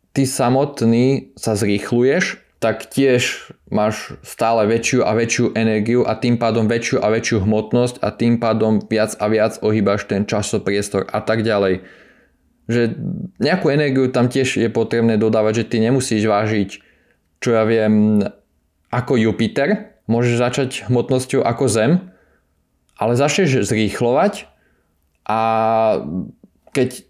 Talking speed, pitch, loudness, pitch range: 130 wpm, 115 Hz, -18 LUFS, 105-125 Hz